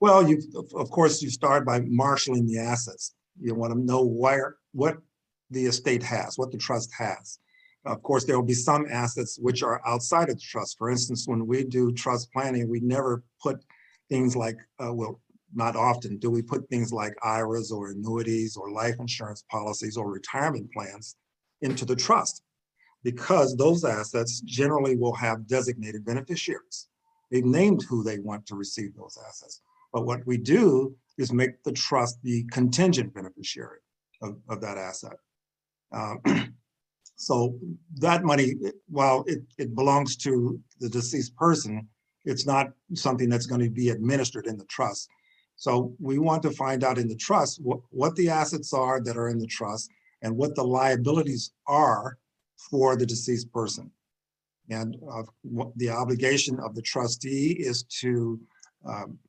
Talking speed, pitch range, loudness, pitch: 165 wpm, 115-135 Hz, -26 LUFS, 125 Hz